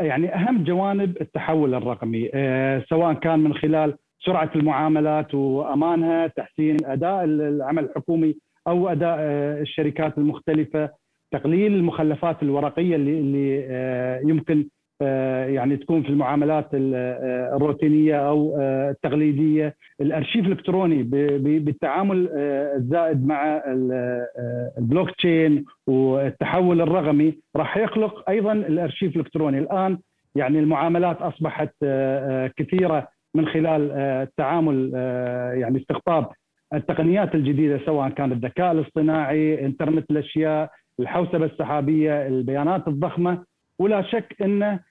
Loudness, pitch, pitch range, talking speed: -22 LUFS, 155 Hz, 140-165 Hz, 95 wpm